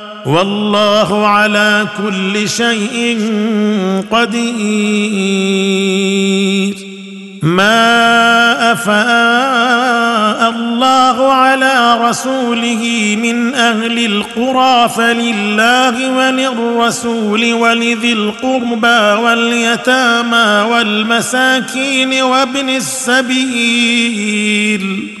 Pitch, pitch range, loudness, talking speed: 235 Hz, 210-235 Hz, -11 LUFS, 50 wpm